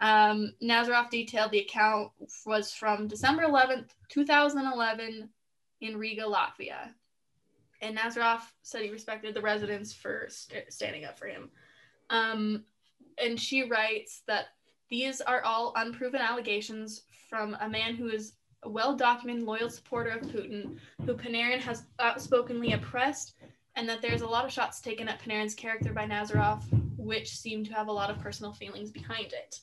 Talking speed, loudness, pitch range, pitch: 155 wpm, -31 LUFS, 215-240 Hz, 225 Hz